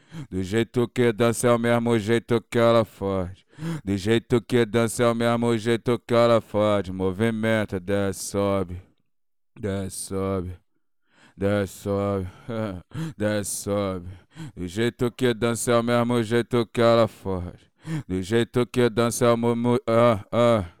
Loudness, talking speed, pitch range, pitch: -23 LUFS, 145 wpm, 100-120 Hz, 115 Hz